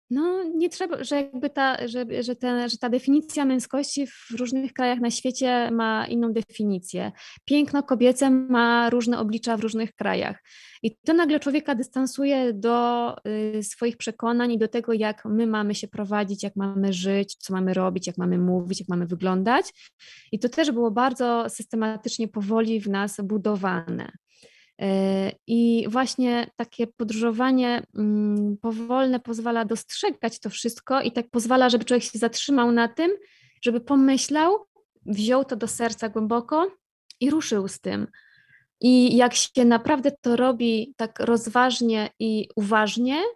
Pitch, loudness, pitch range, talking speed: 235 Hz, -24 LUFS, 220-260 Hz, 150 wpm